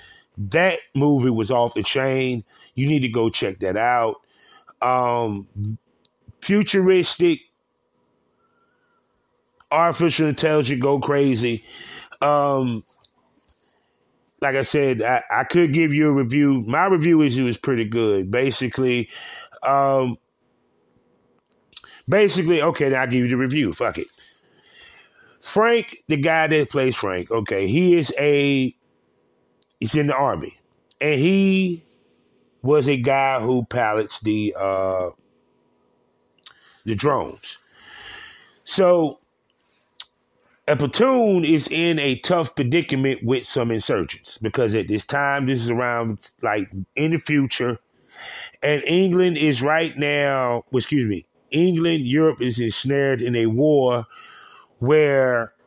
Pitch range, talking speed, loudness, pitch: 120-165 Hz, 120 wpm, -20 LUFS, 140 Hz